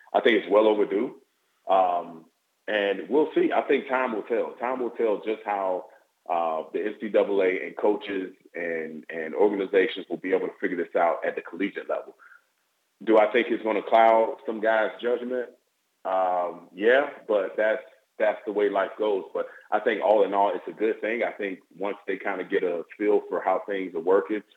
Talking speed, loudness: 200 wpm, -26 LUFS